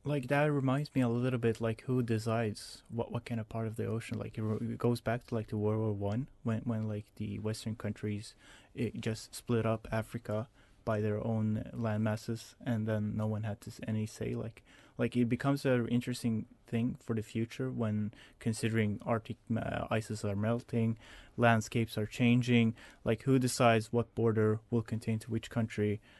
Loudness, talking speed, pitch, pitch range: -34 LUFS, 190 wpm, 115 Hz, 110-120 Hz